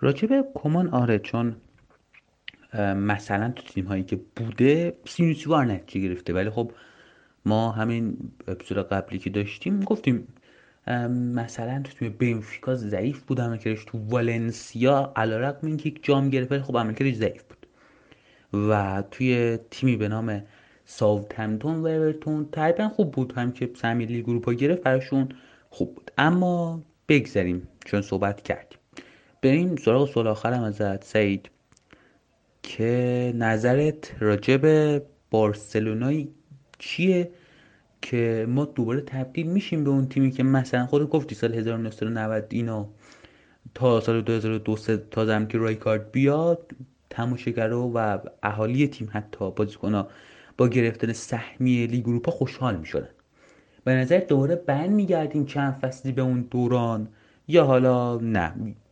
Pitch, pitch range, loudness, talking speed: 120 Hz, 110-140 Hz, -25 LUFS, 130 wpm